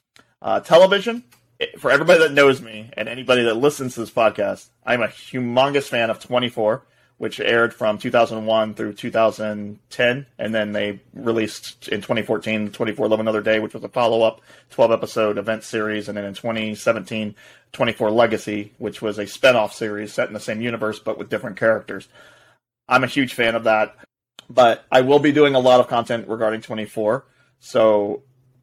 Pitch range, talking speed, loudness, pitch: 110-125 Hz, 170 wpm, -20 LUFS, 110 Hz